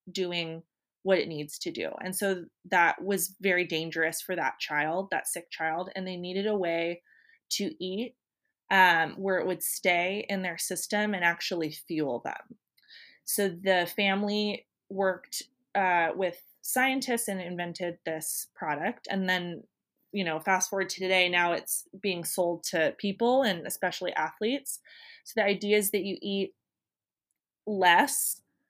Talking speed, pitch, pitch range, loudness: 155 wpm, 185 Hz, 175-205 Hz, -29 LUFS